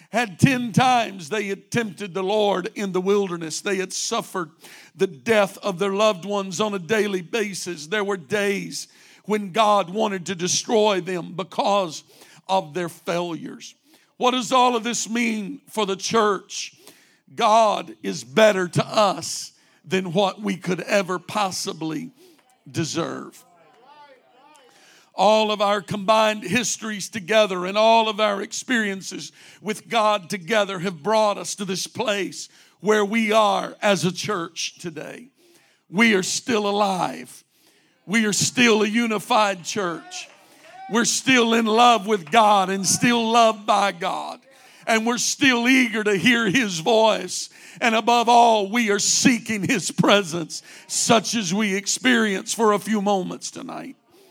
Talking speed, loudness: 145 wpm, -21 LUFS